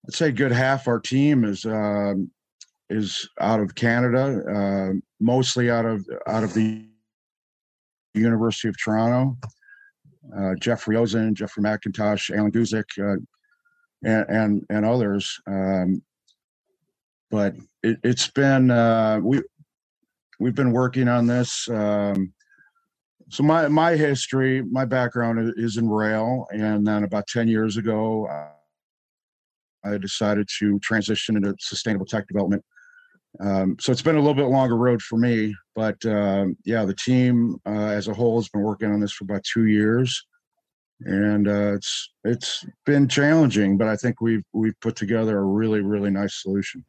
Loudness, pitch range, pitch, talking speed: -22 LUFS, 105-125 Hz, 110 Hz, 150 wpm